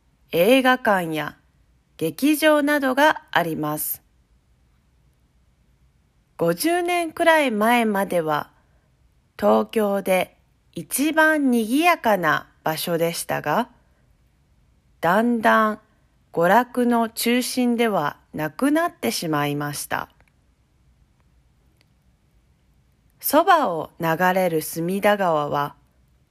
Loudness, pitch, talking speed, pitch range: -21 LUFS, 175 Hz, 155 characters per minute, 145-240 Hz